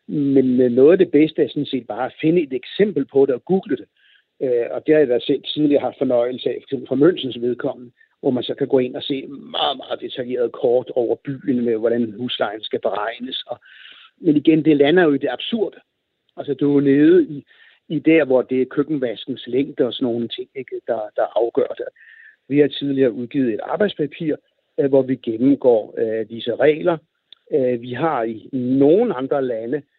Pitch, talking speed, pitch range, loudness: 140 Hz, 200 wpm, 125-175 Hz, -19 LUFS